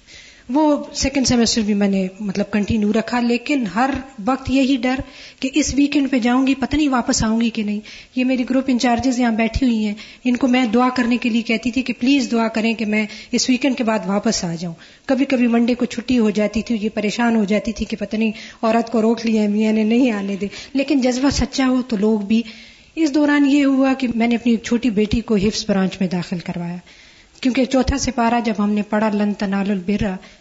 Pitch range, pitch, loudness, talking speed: 215-255 Hz, 235 Hz, -18 LUFS, 225 wpm